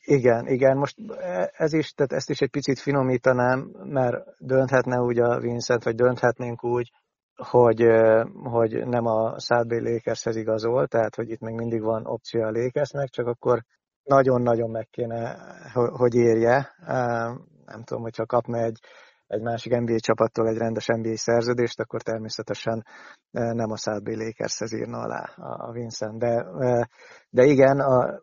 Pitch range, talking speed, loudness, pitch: 115-125 Hz, 145 wpm, -24 LUFS, 120 Hz